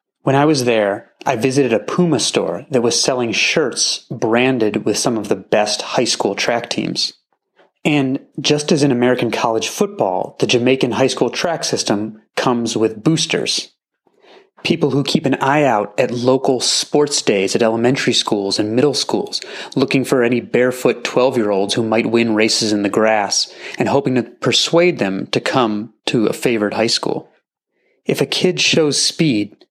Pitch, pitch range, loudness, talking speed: 125 Hz, 110-150 Hz, -16 LUFS, 175 wpm